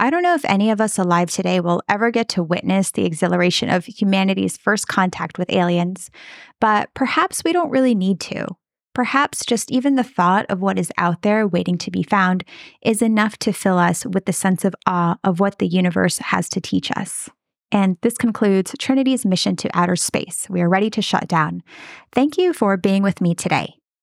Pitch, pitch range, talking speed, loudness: 195 Hz, 180-230 Hz, 205 wpm, -19 LUFS